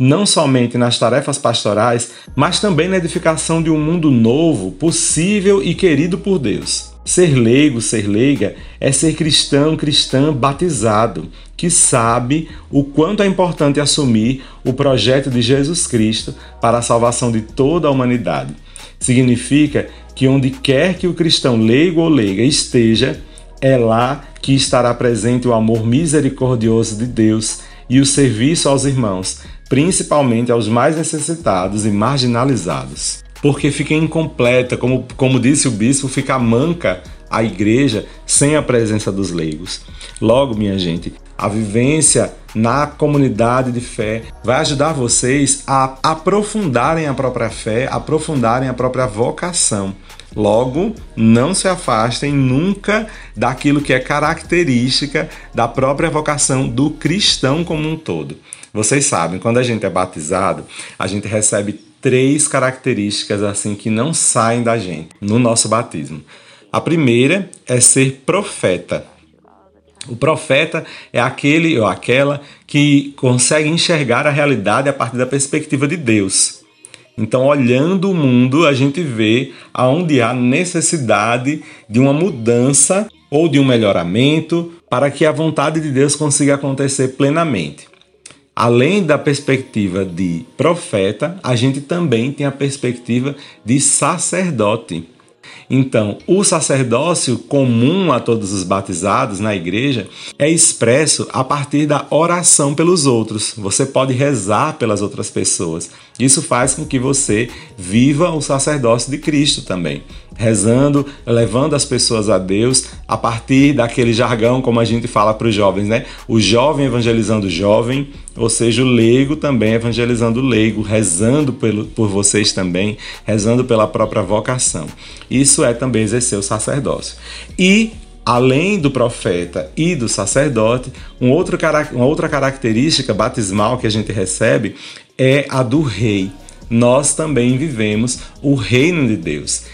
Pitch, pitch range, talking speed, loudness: 130 Hz, 115-145 Hz, 140 wpm, -14 LUFS